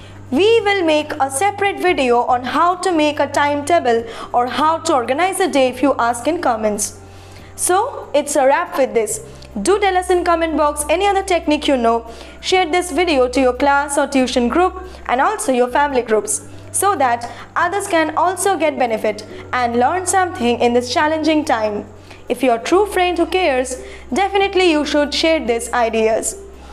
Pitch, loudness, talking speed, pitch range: 295 Hz, -16 LUFS, 180 wpm, 245-360 Hz